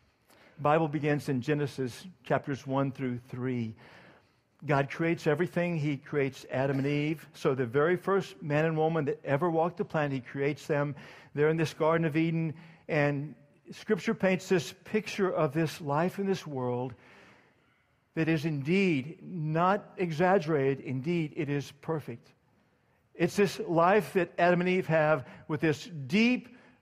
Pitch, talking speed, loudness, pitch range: 160 Hz, 150 wpm, -30 LUFS, 140-175 Hz